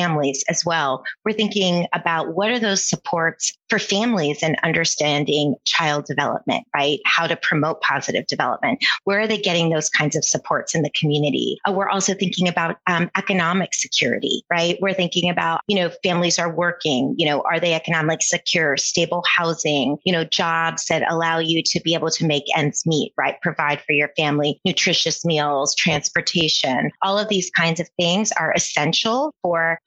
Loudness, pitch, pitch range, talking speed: -19 LUFS, 170 Hz, 155-185 Hz, 175 wpm